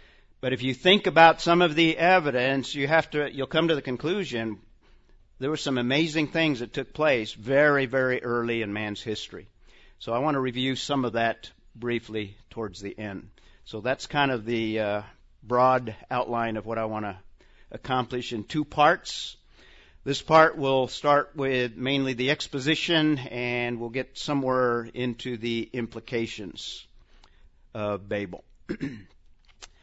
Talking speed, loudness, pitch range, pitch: 155 wpm, -25 LUFS, 115-140 Hz, 125 Hz